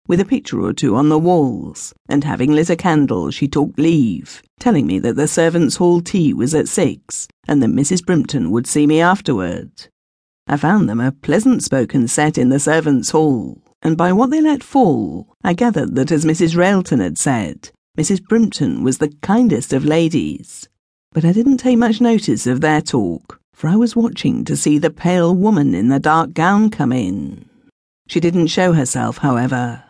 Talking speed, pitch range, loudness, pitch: 190 wpm, 145-190 Hz, -15 LUFS, 160 Hz